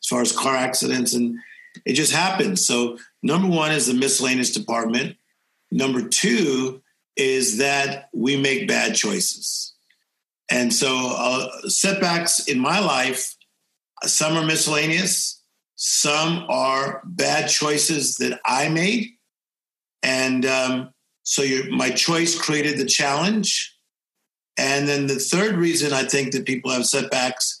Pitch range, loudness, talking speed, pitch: 130-170 Hz, -20 LUFS, 135 wpm, 140 Hz